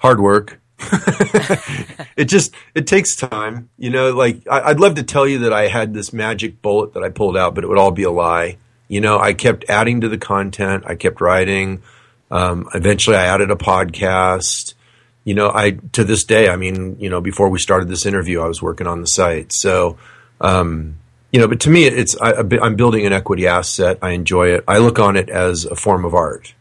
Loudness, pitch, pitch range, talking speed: -15 LUFS, 105 Hz, 95-120 Hz, 220 wpm